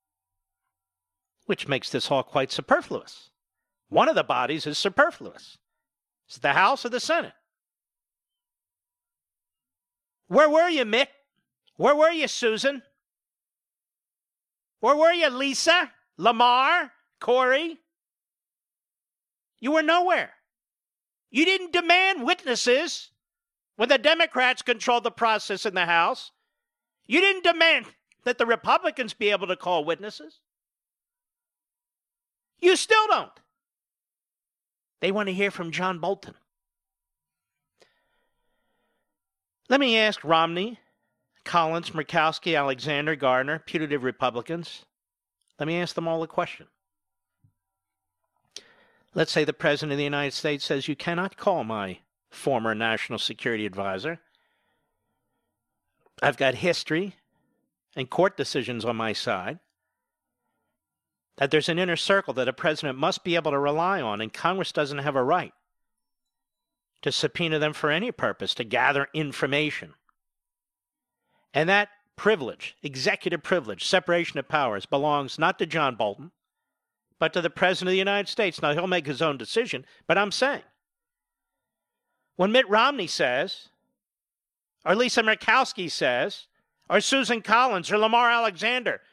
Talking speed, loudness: 125 wpm, -24 LUFS